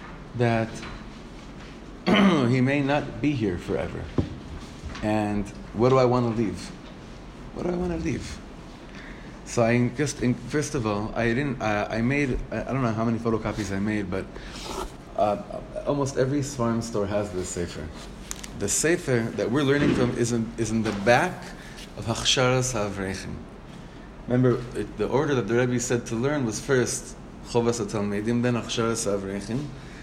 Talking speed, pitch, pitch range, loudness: 160 wpm, 120 Hz, 110-130 Hz, -25 LUFS